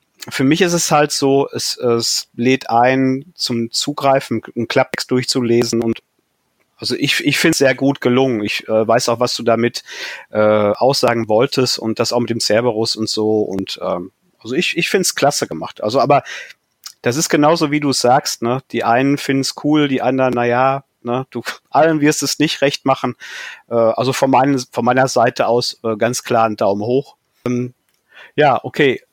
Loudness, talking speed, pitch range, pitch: -16 LUFS, 185 wpm, 115-135 Hz, 125 Hz